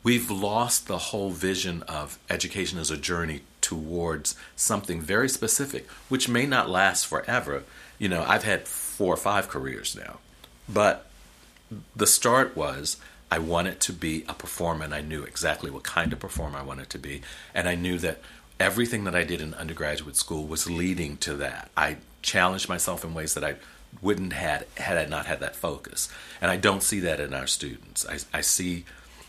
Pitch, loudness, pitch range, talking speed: 85 Hz, -27 LUFS, 75-95 Hz, 185 wpm